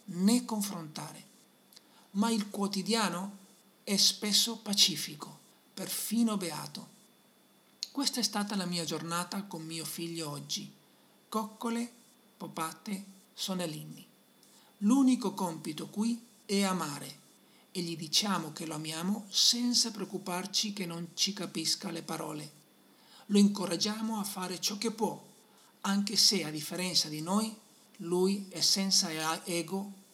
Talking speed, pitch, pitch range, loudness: 115 wpm, 195 Hz, 170-215 Hz, -31 LUFS